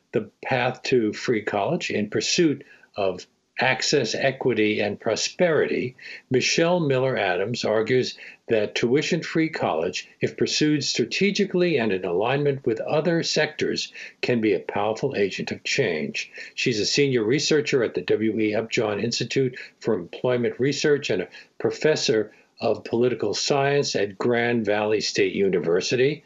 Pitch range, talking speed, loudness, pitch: 115-150 Hz, 135 wpm, -23 LUFS, 135 Hz